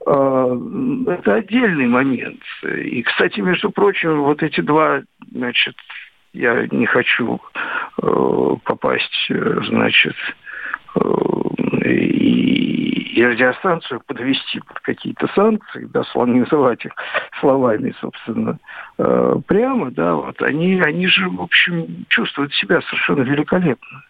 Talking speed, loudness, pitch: 95 wpm, -17 LUFS, 180 Hz